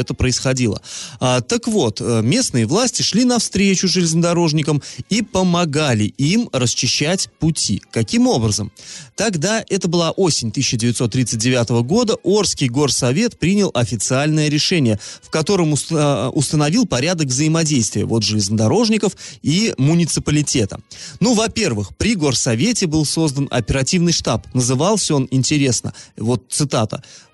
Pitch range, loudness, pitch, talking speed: 125-180 Hz, -17 LUFS, 150 Hz, 110 wpm